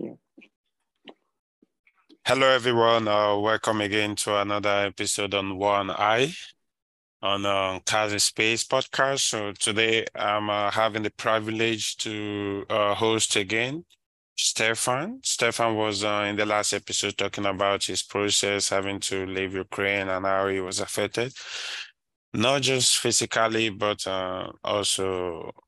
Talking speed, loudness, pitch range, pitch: 125 wpm, -24 LUFS, 100-110 Hz, 105 Hz